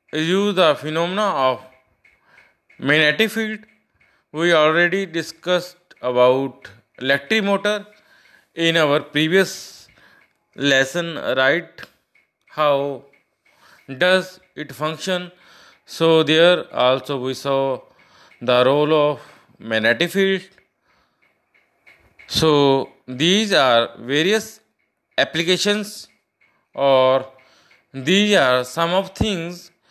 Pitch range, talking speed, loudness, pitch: 135-190 Hz, 85 wpm, -18 LUFS, 160 Hz